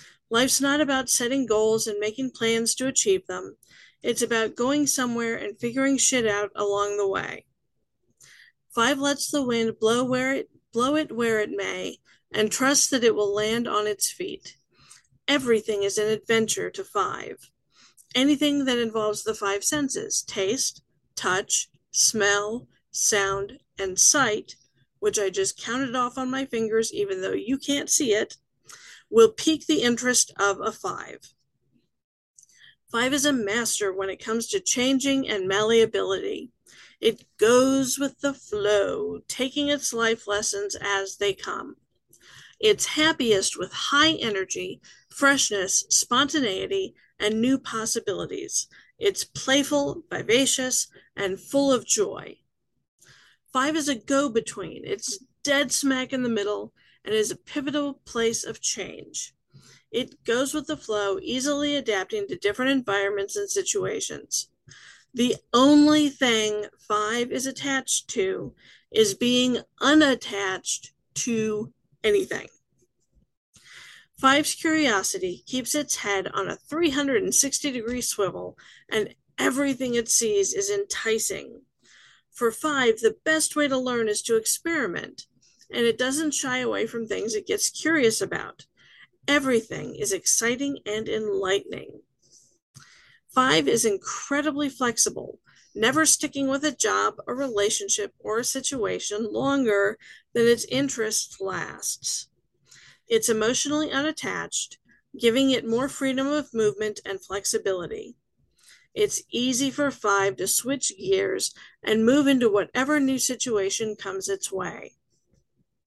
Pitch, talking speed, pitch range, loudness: 260 Hz, 130 wpm, 220-300 Hz, -24 LUFS